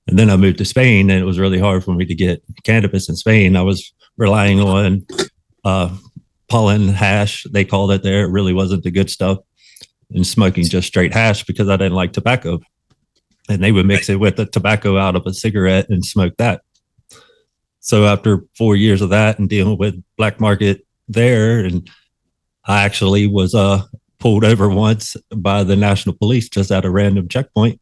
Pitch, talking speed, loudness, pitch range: 100 Hz, 190 wpm, -15 LUFS, 95-110 Hz